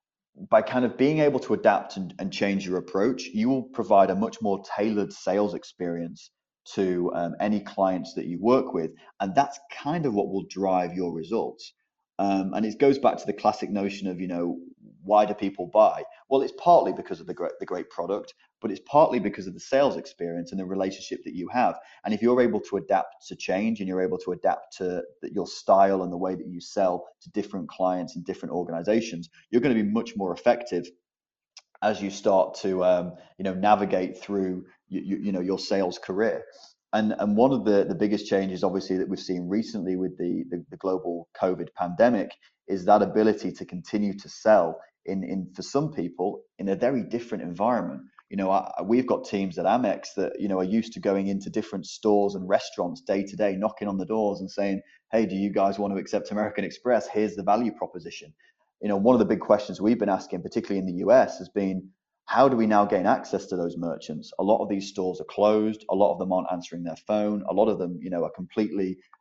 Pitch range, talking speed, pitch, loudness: 95-105 Hz, 225 wpm, 100 Hz, -26 LUFS